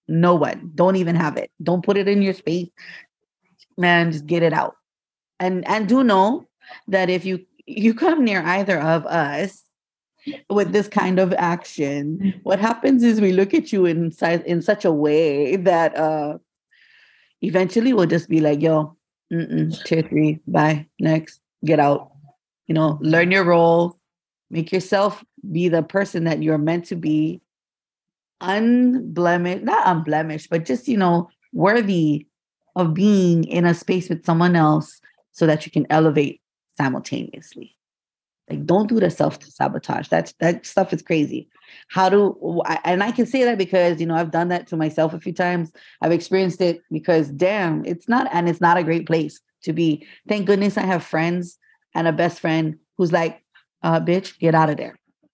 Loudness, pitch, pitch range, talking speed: -20 LUFS, 175 Hz, 160-195 Hz, 175 wpm